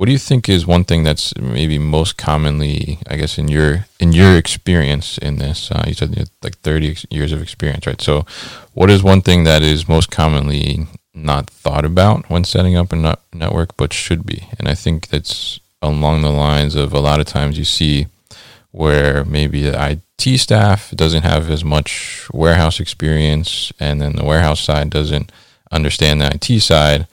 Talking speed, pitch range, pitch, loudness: 190 wpm, 75-90 Hz, 80 Hz, -15 LUFS